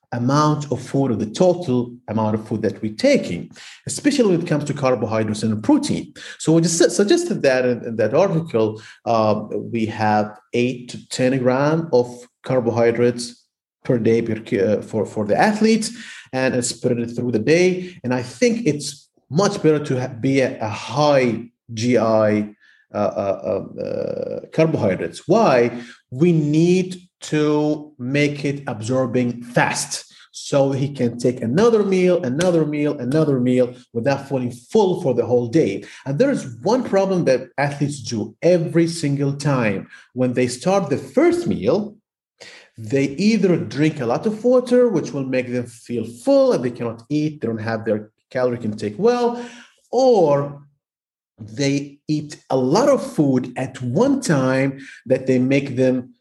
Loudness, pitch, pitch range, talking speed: -19 LUFS, 135 Hz, 120-165 Hz, 155 wpm